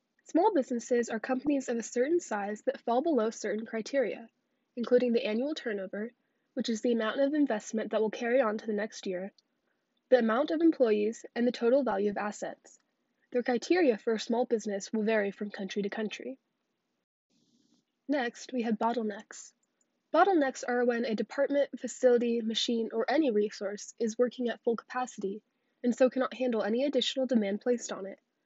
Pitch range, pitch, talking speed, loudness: 220-260 Hz, 240 Hz, 175 wpm, -30 LUFS